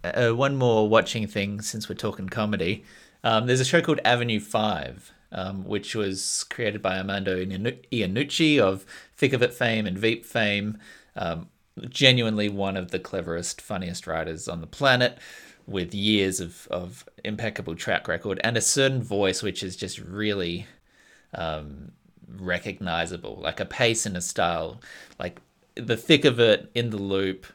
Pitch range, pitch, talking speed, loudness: 95-115 Hz, 105 Hz, 160 wpm, -25 LUFS